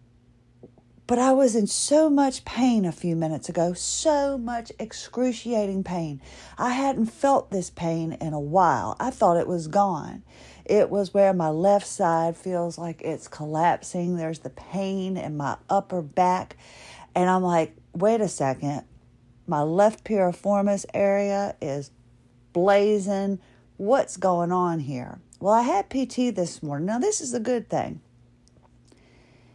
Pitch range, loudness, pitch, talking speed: 155-210 Hz, -24 LUFS, 180 Hz, 150 wpm